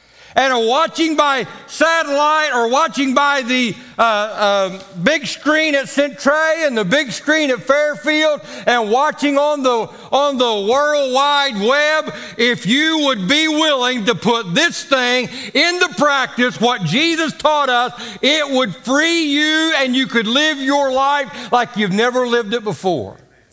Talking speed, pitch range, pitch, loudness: 155 wpm, 240-295 Hz, 275 Hz, -15 LUFS